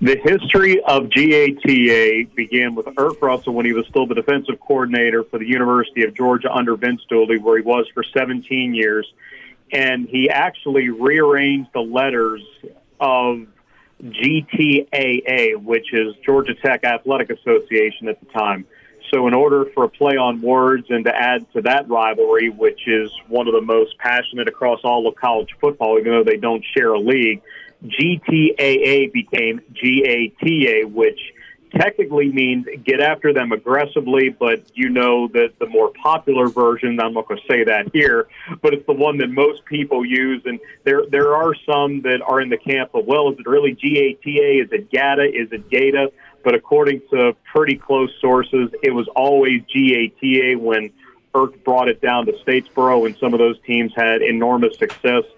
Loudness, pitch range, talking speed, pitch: -17 LUFS, 120-145 Hz, 180 wpm, 130 Hz